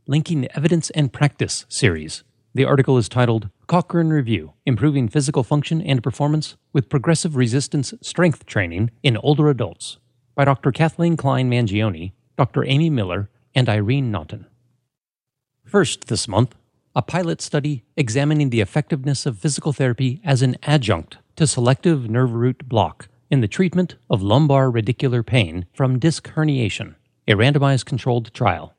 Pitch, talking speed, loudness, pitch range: 130 Hz, 145 wpm, -20 LUFS, 120-150 Hz